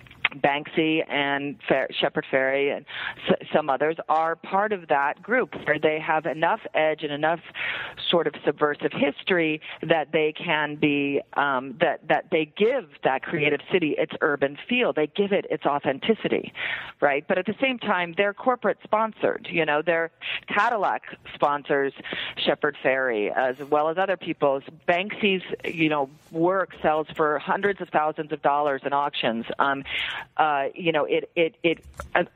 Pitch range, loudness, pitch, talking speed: 145-180 Hz, -24 LUFS, 155 Hz, 160 wpm